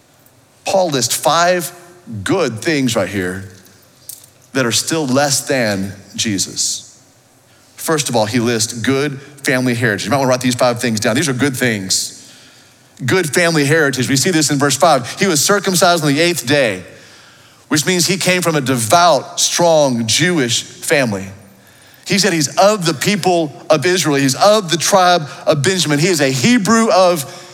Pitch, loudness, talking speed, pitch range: 145 Hz, -14 LUFS, 170 wpm, 125-175 Hz